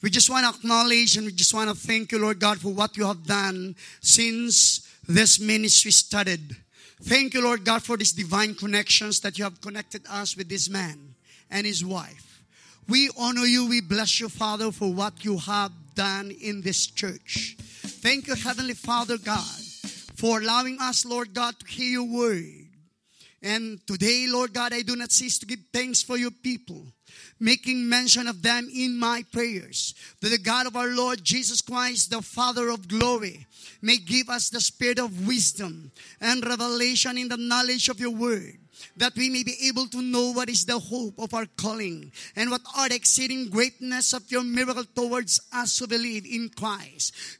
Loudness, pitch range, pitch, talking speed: -23 LUFS, 205-245 Hz, 230 Hz, 185 wpm